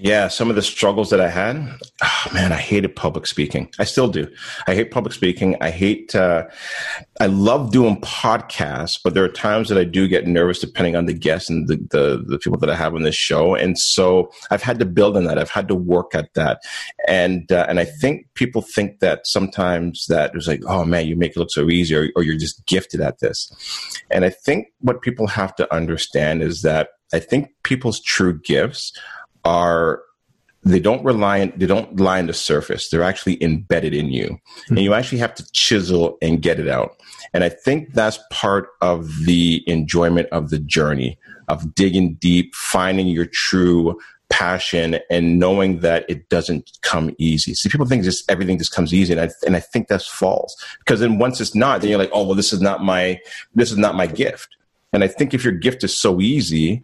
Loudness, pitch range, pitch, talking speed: -18 LUFS, 85-100 Hz, 90 Hz, 215 wpm